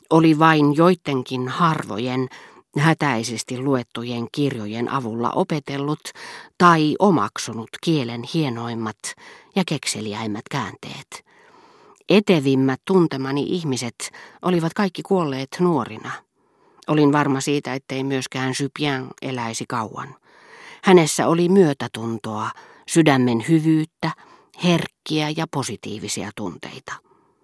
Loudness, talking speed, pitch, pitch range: -21 LUFS, 85 wpm, 145 Hz, 125-170 Hz